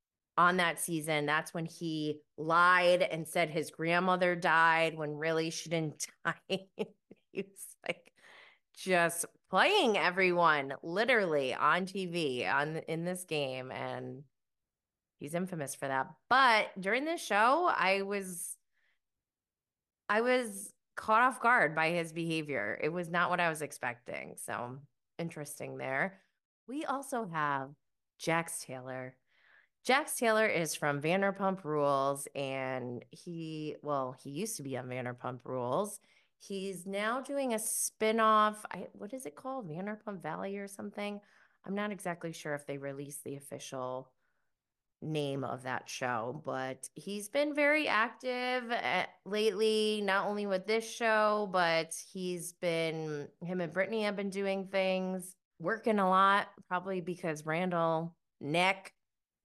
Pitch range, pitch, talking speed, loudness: 150-200 Hz, 175 Hz, 135 wpm, -32 LUFS